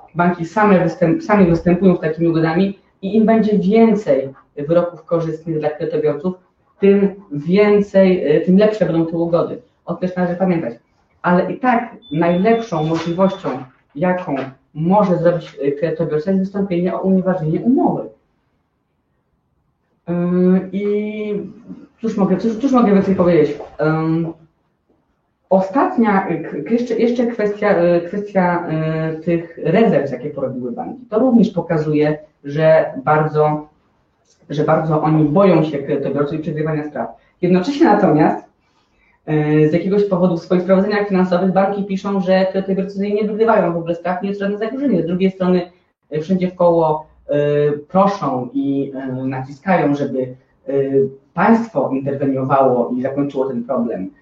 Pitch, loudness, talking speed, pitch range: 175 Hz, -17 LUFS, 120 wpm, 150-195 Hz